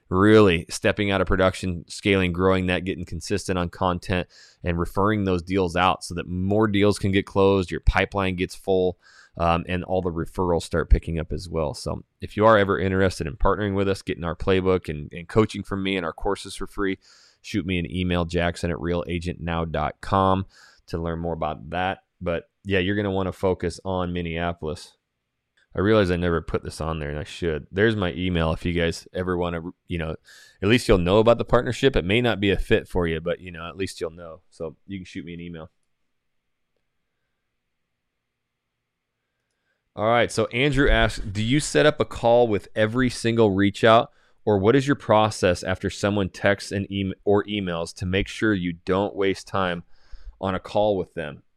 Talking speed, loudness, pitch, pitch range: 200 wpm, -23 LUFS, 95 Hz, 85-100 Hz